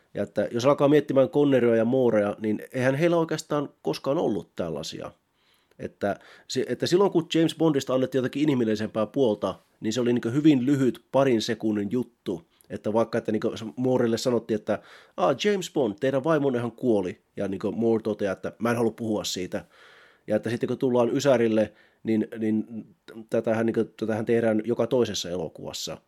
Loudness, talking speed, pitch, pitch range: -25 LUFS, 170 wpm, 115 Hz, 110-135 Hz